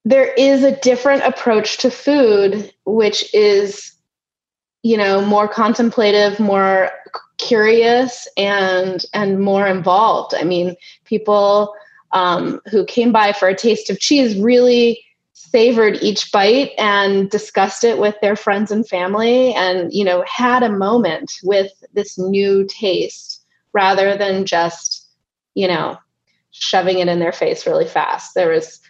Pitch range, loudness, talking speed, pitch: 195-245 Hz, -15 LUFS, 140 wpm, 210 Hz